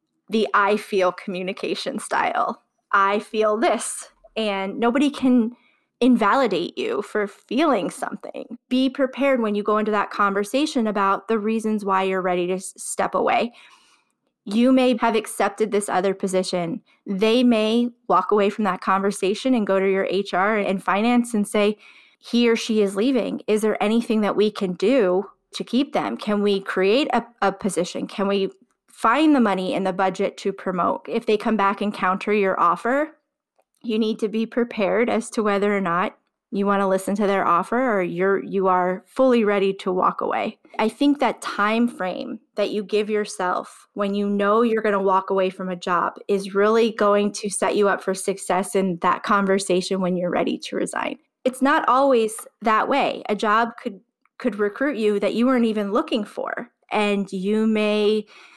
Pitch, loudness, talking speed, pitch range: 210 Hz, -21 LUFS, 180 wpm, 195-235 Hz